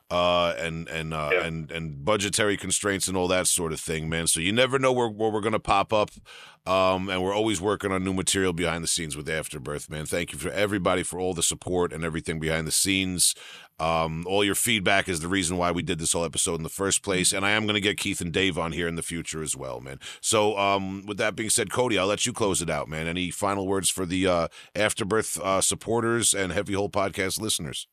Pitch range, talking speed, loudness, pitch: 85-100 Hz, 245 wpm, -25 LUFS, 95 Hz